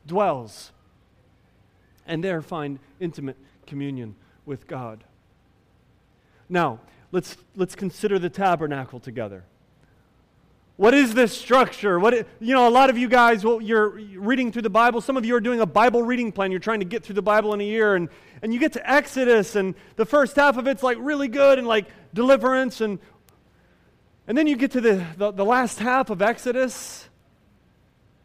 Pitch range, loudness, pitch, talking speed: 170-245 Hz, -21 LUFS, 215 Hz, 180 wpm